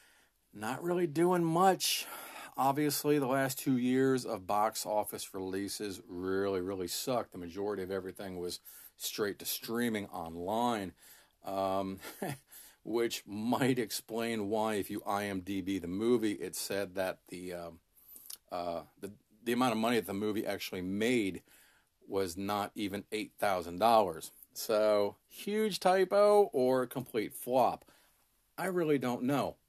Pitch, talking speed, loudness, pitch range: 105 Hz, 130 wpm, -33 LUFS, 95-130 Hz